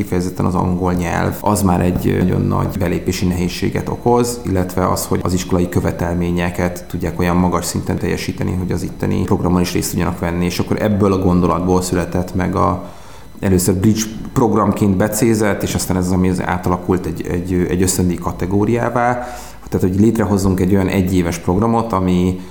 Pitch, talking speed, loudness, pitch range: 90 Hz, 170 wpm, -17 LUFS, 90-100 Hz